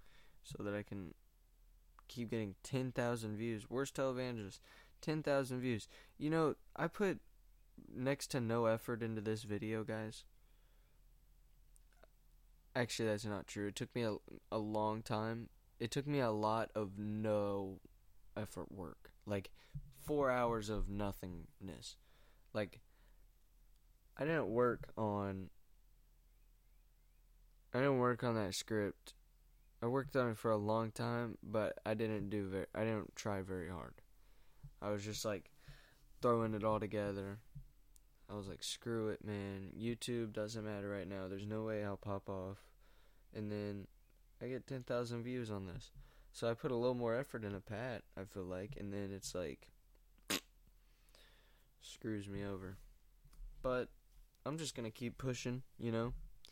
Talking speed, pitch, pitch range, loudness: 150 wpm, 110 Hz, 100-125 Hz, -42 LUFS